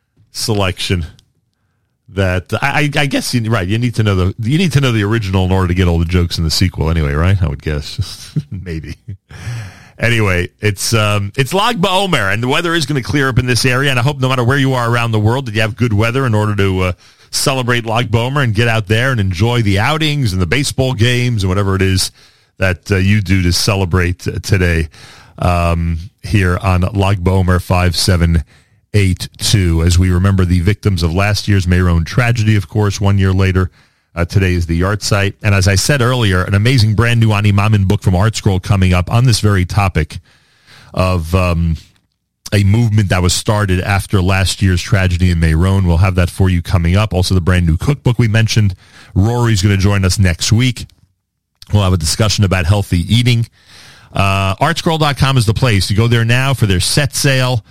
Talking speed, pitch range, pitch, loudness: 205 wpm, 90-115 Hz, 100 Hz, -14 LUFS